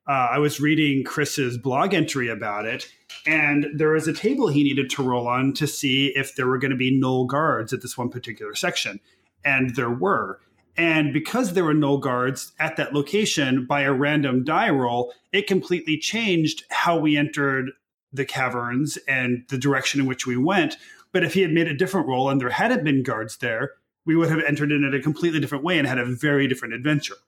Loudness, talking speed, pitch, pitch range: -22 LUFS, 210 wpm, 140 Hz, 130-155 Hz